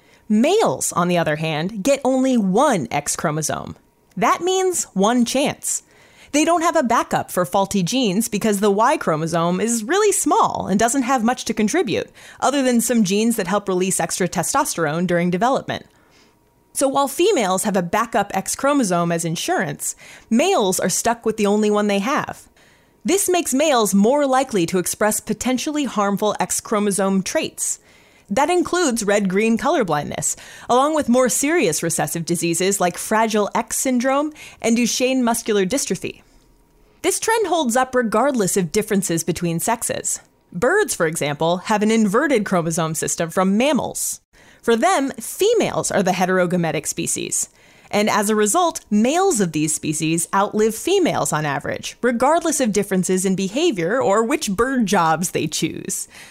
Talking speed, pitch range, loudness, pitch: 155 wpm, 185-265 Hz, -19 LUFS, 215 Hz